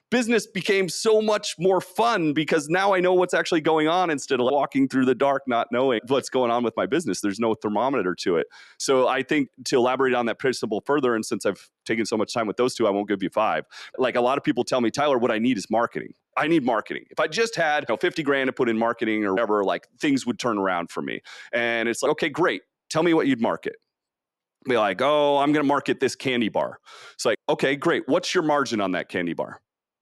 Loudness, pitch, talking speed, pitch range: -23 LUFS, 145 Hz, 250 wpm, 120-185 Hz